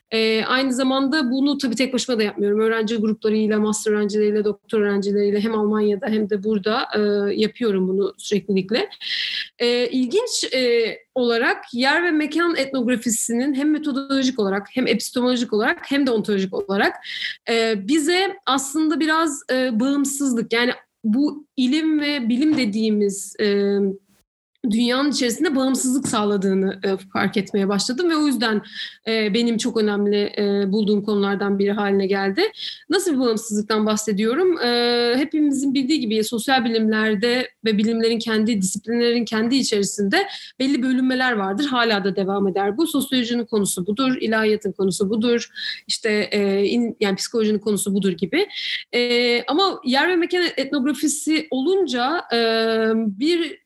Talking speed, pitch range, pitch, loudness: 140 wpm, 210-270 Hz, 230 Hz, -20 LUFS